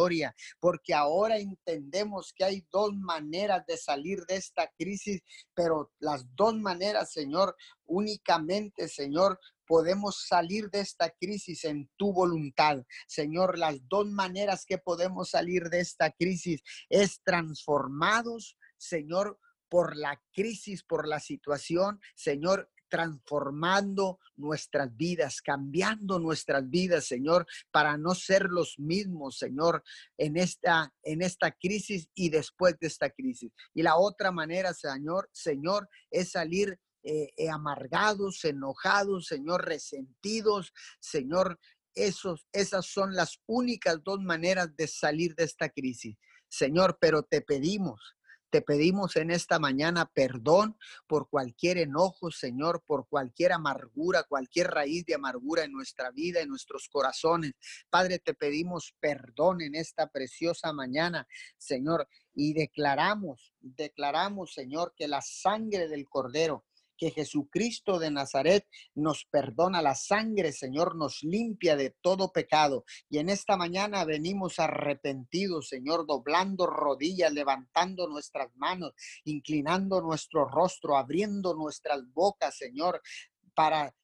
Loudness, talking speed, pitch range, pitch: -30 LUFS, 125 wpm, 150-190 Hz, 170 Hz